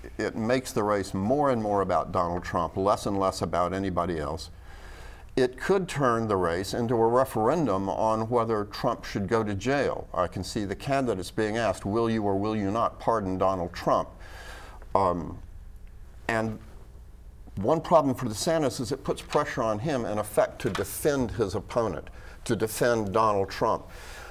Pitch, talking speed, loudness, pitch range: 105 Hz, 175 wpm, -27 LUFS, 95-120 Hz